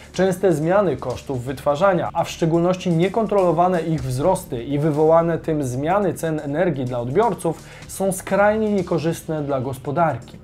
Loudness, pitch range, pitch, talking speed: -20 LUFS, 145-185 Hz, 165 Hz, 130 wpm